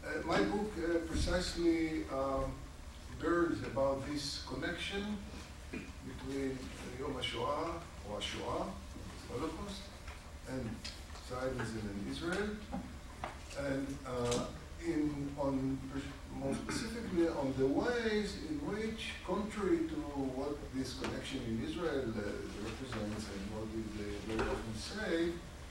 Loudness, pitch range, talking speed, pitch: -38 LUFS, 110-170 Hz, 105 wpm, 135 Hz